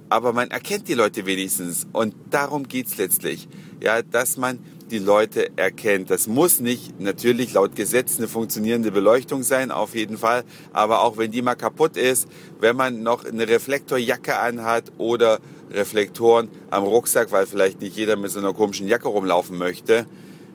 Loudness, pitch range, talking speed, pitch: -21 LUFS, 105-130 Hz, 170 wpm, 115 Hz